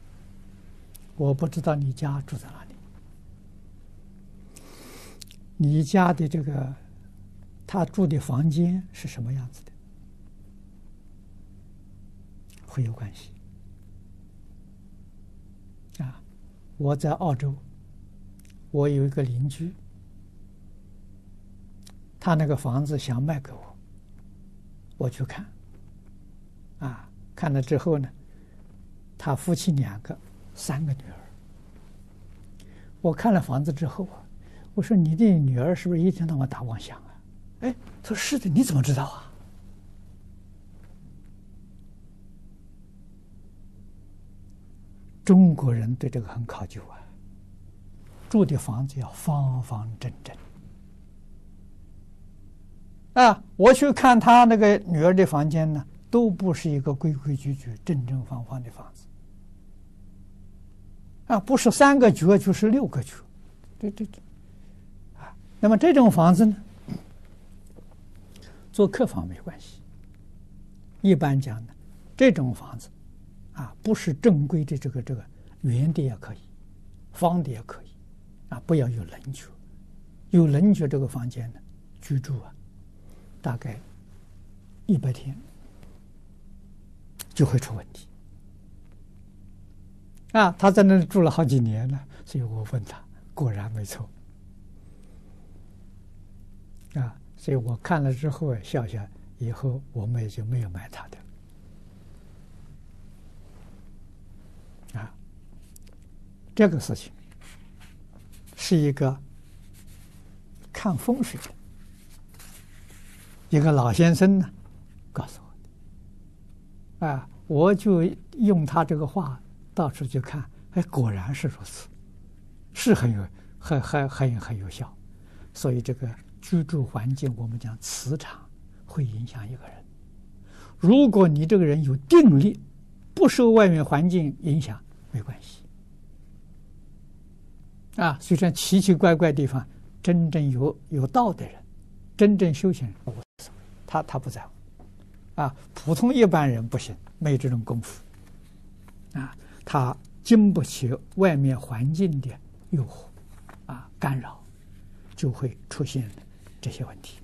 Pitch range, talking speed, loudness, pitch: 95-145 Hz, 165 characters per minute, -23 LUFS, 100 Hz